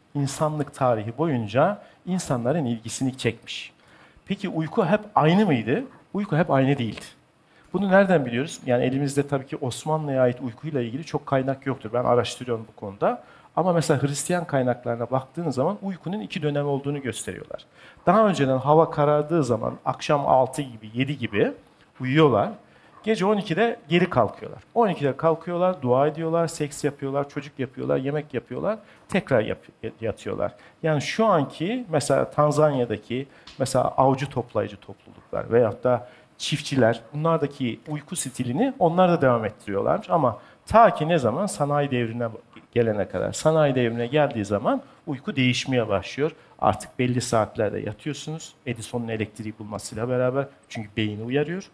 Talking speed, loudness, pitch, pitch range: 135 wpm, -24 LUFS, 140 Hz, 125-160 Hz